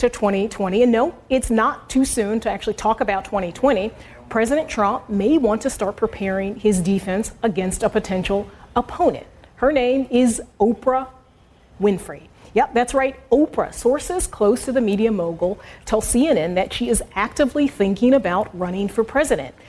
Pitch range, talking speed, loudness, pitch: 200-260 Hz, 160 wpm, -20 LUFS, 225 Hz